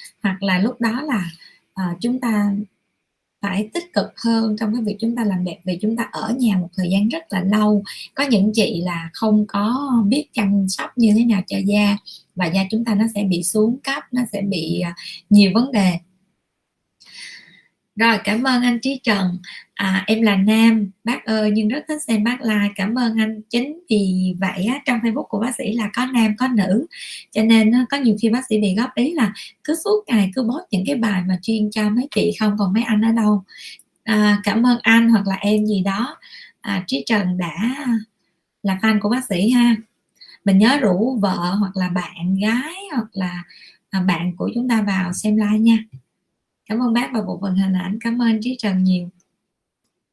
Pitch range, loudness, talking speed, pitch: 195-235 Hz, -19 LUFS, 205 wpm, 215 Hz